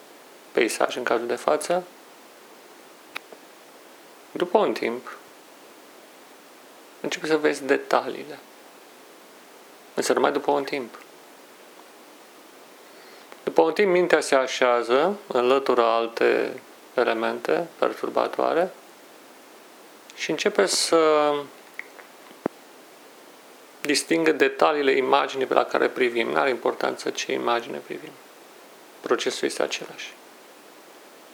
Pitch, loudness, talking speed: 160 Hz, -23 LUFS, 90 wpm